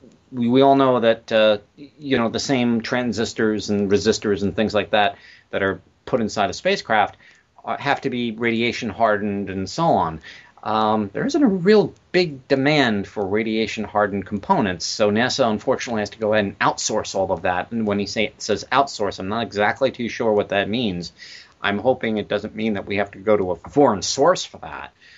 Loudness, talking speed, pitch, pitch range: -21 LUFS, 205 wpm, 110 Hz, 105-125 Hz